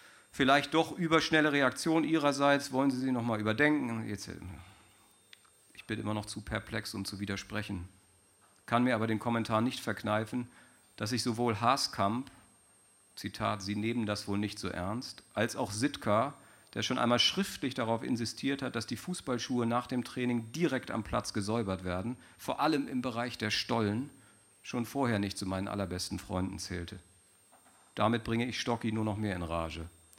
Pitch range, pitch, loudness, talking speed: 100-125 Hz, 115 Hz, -33 LUFS, 165 wpm